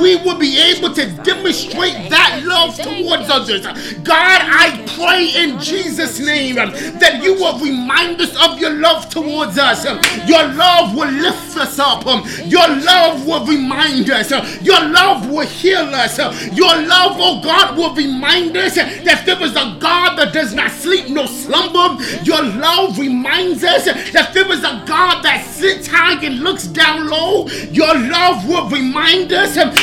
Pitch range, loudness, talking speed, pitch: 300-355 Hz, -12 LUFS, 165 wpm, 330 Hz